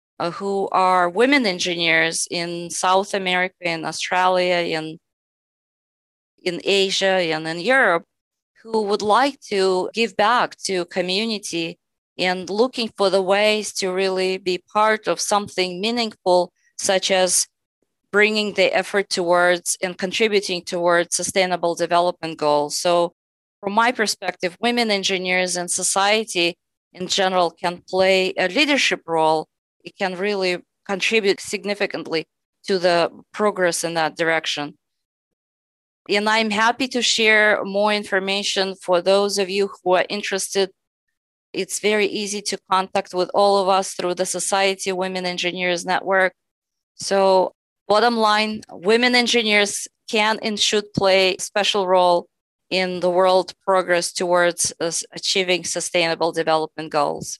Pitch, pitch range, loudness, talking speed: 185 Hz, 175-205 Hz, -20 LUFS, 130 wpm